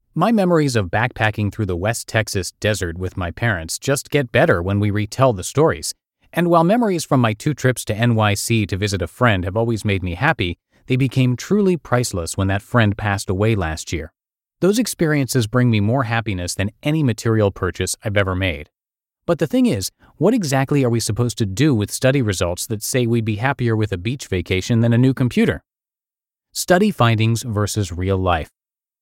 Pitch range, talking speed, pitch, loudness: 100-135 Hz, 195 wpm, 115 Hz, -19 LUFS